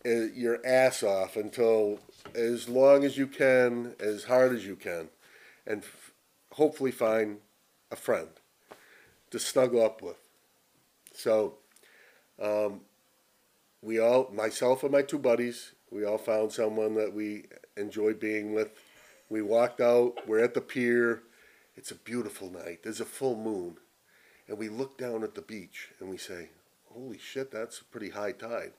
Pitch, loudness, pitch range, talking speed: 115 Hz, -29 LUFS, 110-130 Hz, 155 wpm